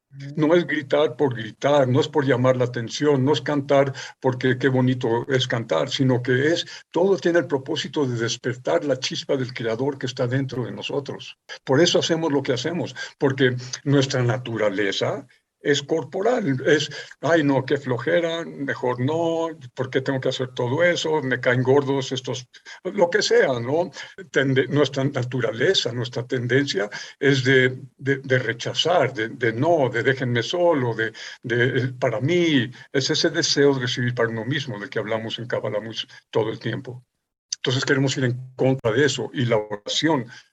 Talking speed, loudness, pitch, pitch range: 175 wpm, -22 LUFS, 135 Hz, 125-145 Hz